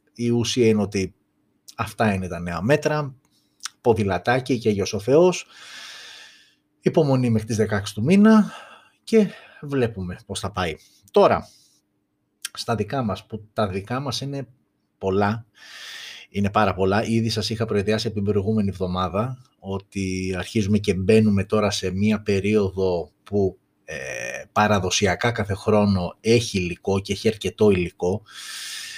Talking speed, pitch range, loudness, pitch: 135 wpm, 95-115 Hz, -22 LUFS, 105 Hz